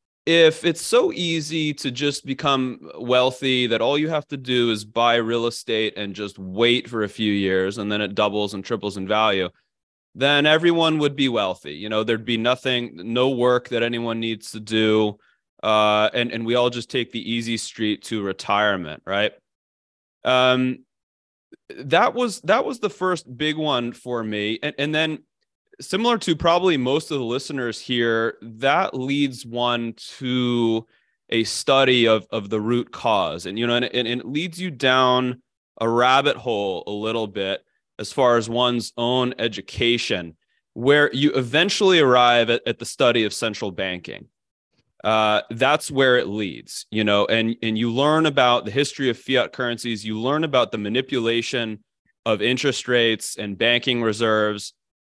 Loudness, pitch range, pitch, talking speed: -21 LUFS, 110-135 Hz, 120 Hz, 170 wpm